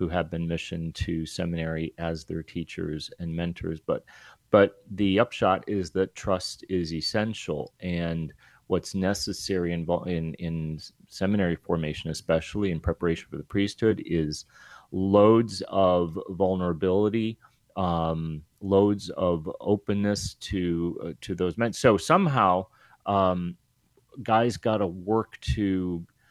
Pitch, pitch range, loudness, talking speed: 90 Hz, 85-100 Hz, -27 LUFS, 125 wpm